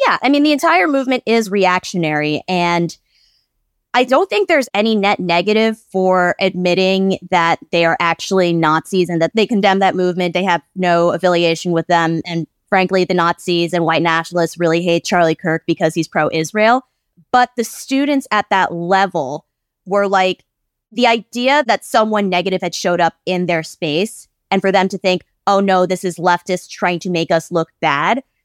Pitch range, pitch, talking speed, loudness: 170-205 Hz, 180 Hz, 180 wpm, -15 LUFS